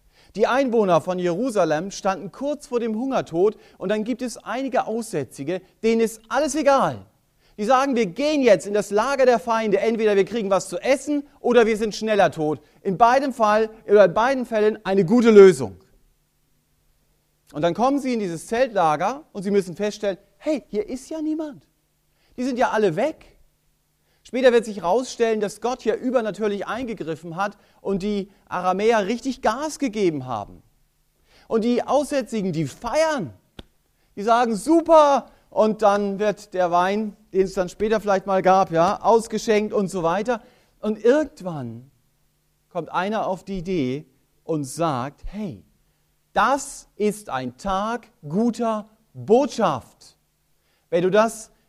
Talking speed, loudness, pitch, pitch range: 150 wpm, -21 LUFS, 210 Hz, 185-240 Hz